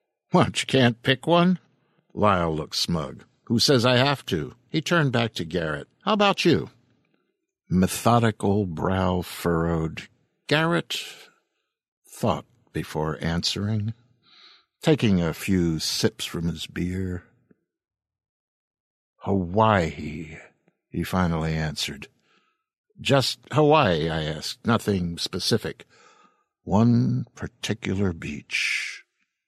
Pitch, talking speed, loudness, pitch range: 100 Hz, 100 wpm, -24 LUFS, 85-125 Hz